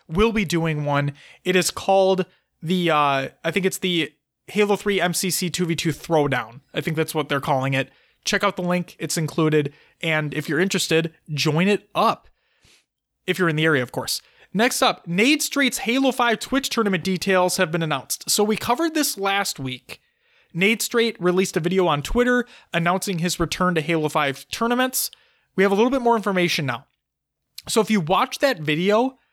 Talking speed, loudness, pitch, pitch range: 185 wpm, -21 LUFS, 180 Hz, 155-210 Hz